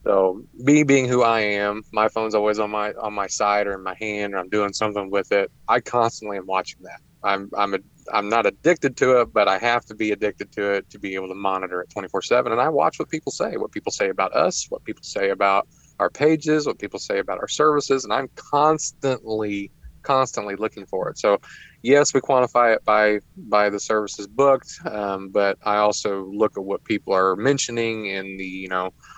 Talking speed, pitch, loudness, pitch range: 220 wpm, 105 Hz, -22 LUFS, 100-125 Hz